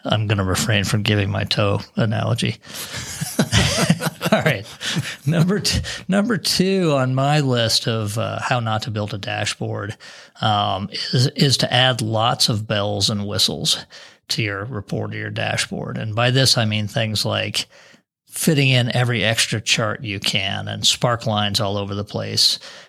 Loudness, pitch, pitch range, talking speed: -19 LUFS, 110 Hz, 105-130 Hz, 165 wpm